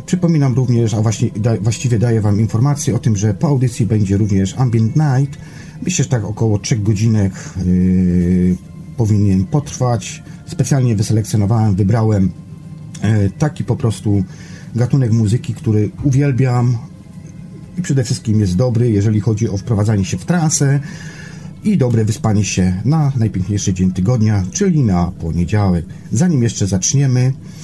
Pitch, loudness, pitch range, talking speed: 115 Hz, -16 LUFS, 105-145 Hz, 130 wpm